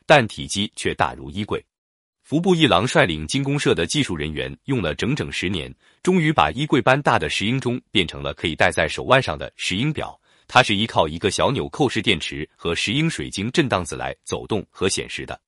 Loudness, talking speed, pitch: -21 LUFS, 310 characters per minute, 110 Hz